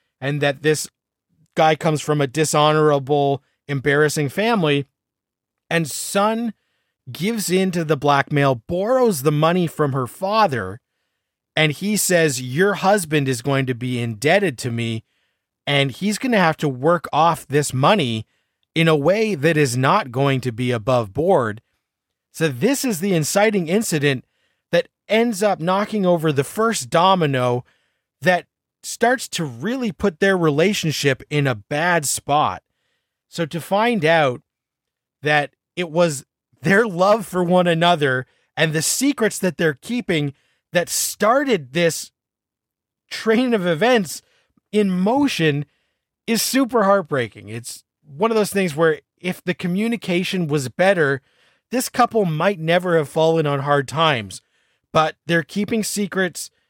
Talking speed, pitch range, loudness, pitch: 140 wpm, 145-200 Hz, -19 LUFS, 165 Hz